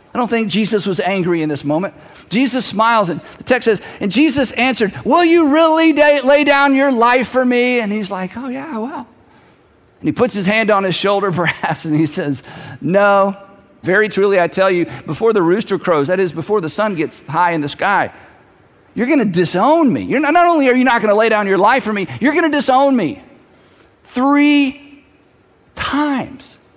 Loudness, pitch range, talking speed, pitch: -14 LUFS, 190-275 Hz, 210 wpm, 220 Hz